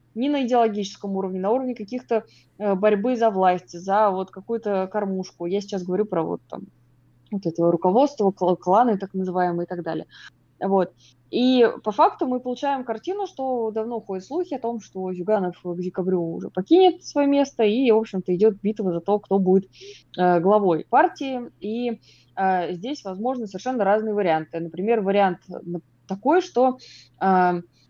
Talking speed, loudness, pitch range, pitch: 160 wpm, -23 LUFS, 180-240 Hz, 200 Hz